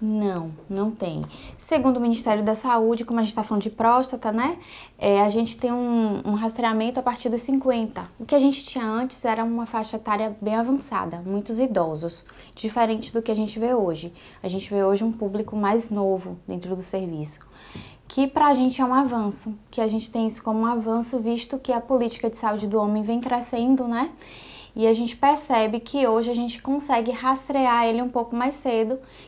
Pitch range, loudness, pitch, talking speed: 215-250 Hz, -24 LUFS, 230 Hz, 205 wpm